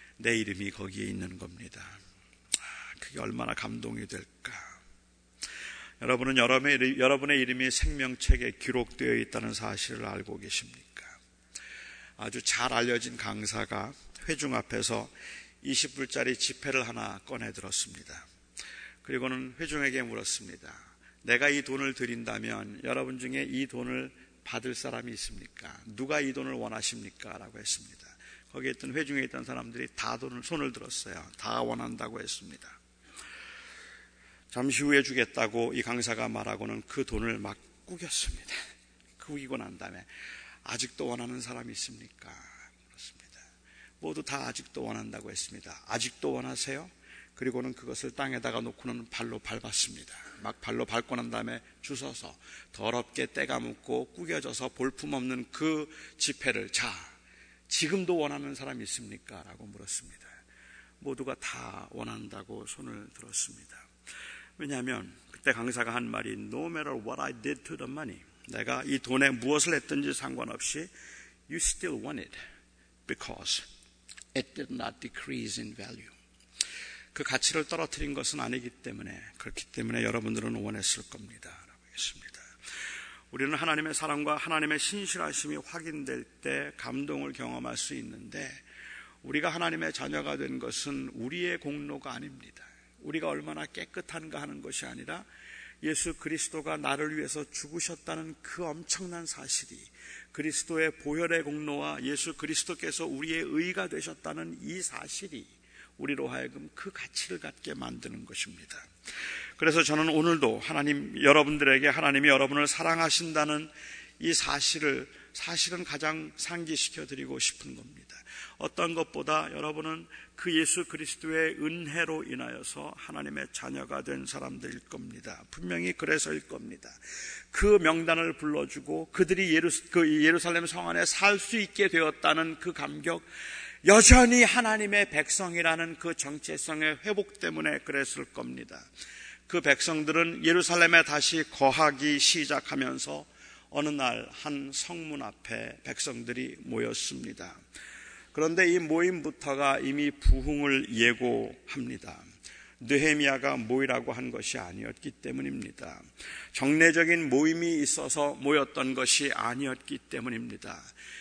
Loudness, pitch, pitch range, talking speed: -30 LUFS, 140 Hz, 115-160 Hz, 325 characters per minute